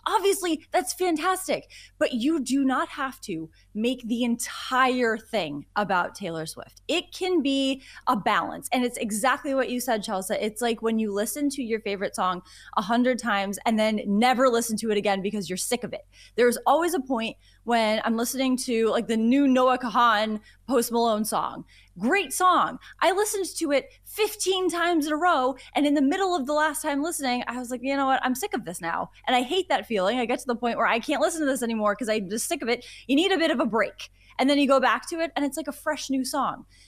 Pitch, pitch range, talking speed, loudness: 255 Hz, 225-295 Hz, 230 wpm, -25 LUFS